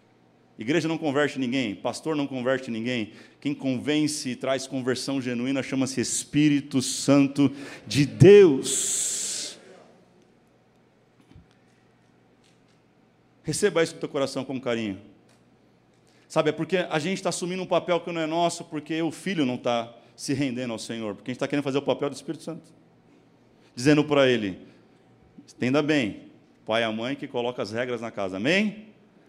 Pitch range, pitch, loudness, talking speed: 120-155 Hz, 140 Hz, -25 LUFS, 150 wpm